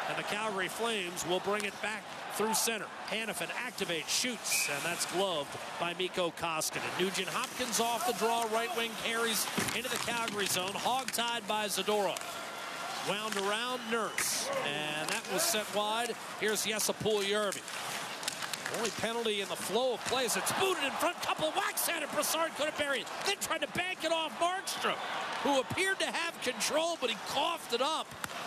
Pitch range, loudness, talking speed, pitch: 200-255 Hz, -32 LUFS, 175 wpm, 225 Hz